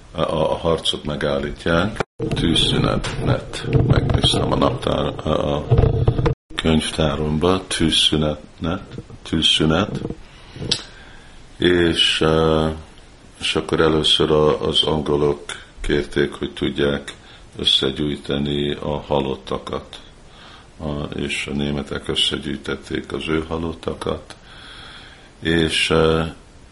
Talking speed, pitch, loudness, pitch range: 70 wpm, 80 Hz, -19 LUFS, 75-80 Hz